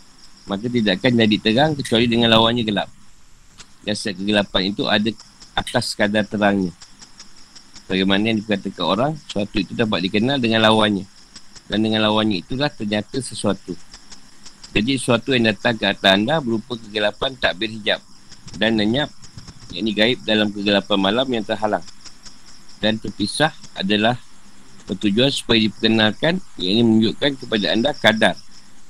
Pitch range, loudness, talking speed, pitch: 100-115 Hz, -19 LUFS, 135 wpm, 110 Hz